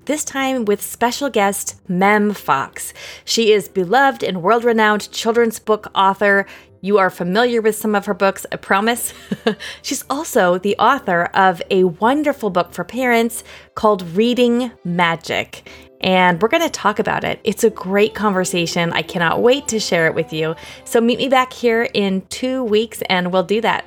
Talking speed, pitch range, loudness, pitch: 175 wpm, 185-235 Hz, -17 LUFS, 210 Hz